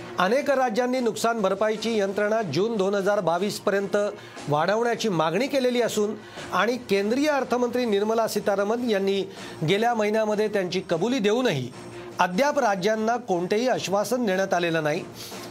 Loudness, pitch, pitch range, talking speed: -24 LUFS, 210 Hz, 190-230 Hz, 120 wpm